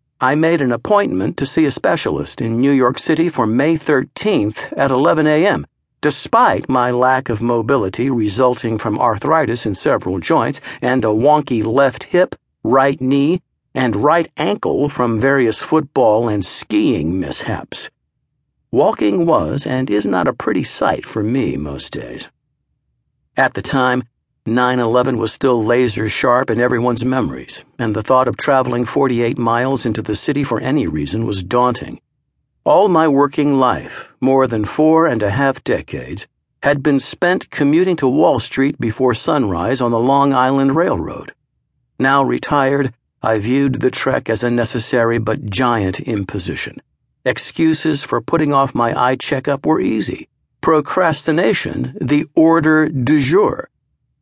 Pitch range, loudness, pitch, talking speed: 115-140 Hz, -16 LUFS, 130 Hz, 150 wpm